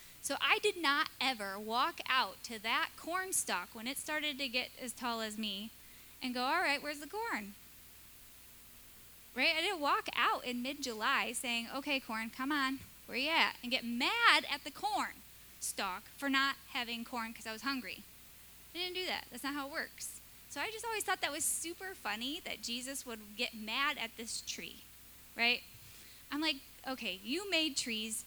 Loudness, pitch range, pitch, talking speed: -35 LUFS, 230-305 Hz, 265 Hz, 195 wpm